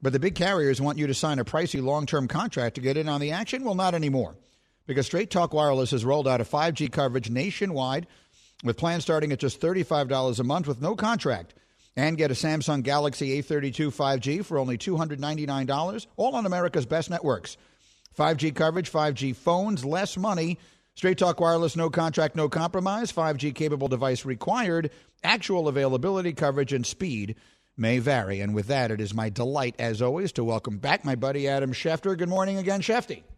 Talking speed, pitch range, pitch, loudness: 185 wpm, 135-170 Hz, 150 Hz, -26 LUFS